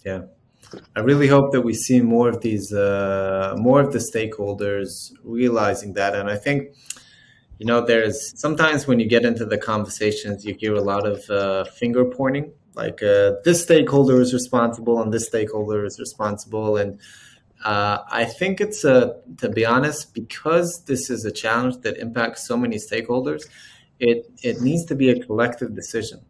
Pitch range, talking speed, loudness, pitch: 105-135 Hz, 175 wpm, -21 LUFS, 115 Hz